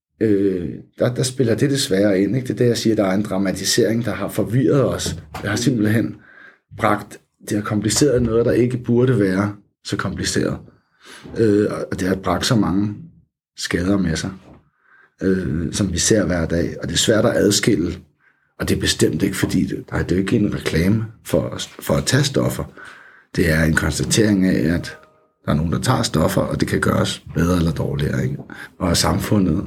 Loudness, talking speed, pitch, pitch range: -19 LUFS, 195 wpm, 100 Hz, 90-110 Hz